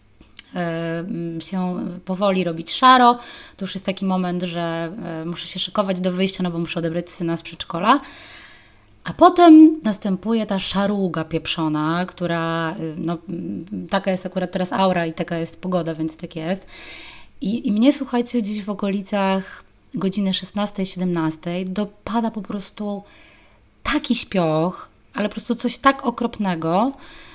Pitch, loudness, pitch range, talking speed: 190 Hz, -21 LUFS, 170-215 Hz, 135 wpm